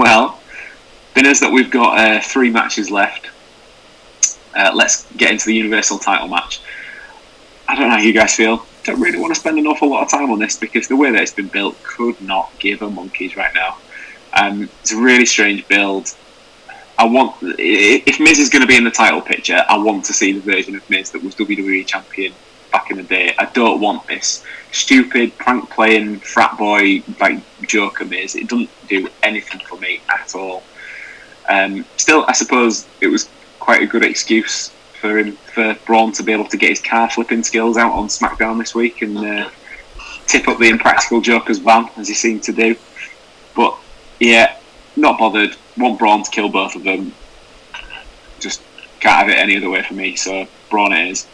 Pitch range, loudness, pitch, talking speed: 105-115 Hz, -14 LUFS, 110 Hz, 195 wpm